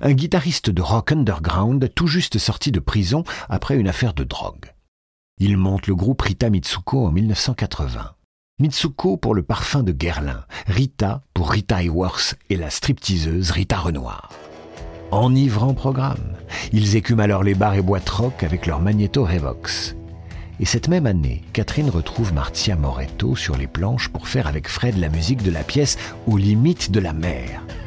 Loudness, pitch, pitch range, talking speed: -20 LUFS, 100 Hz, 85-120 Hz, 170 wpm